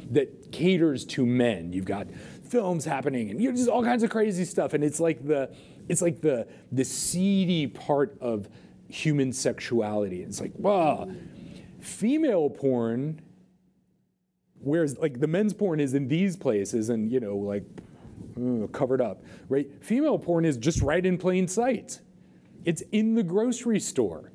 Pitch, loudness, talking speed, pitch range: 160 Hz, -27 LUFS, 160 wpm, 125-185 Hz